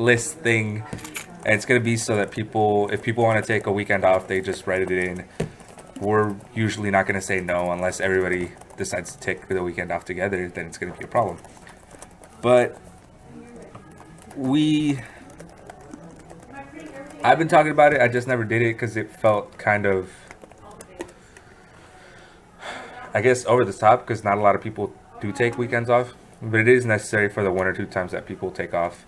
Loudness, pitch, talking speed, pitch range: -22 LUFS, 105 Hz, 190 wpm, 95-120 Hz